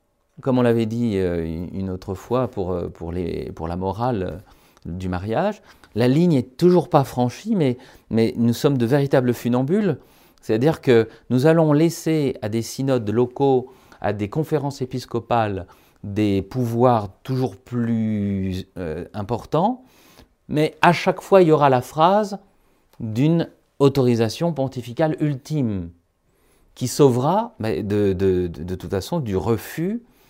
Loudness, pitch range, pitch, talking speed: -21 LUFS, 100-150 Hz, 125 Hz, 125 wpm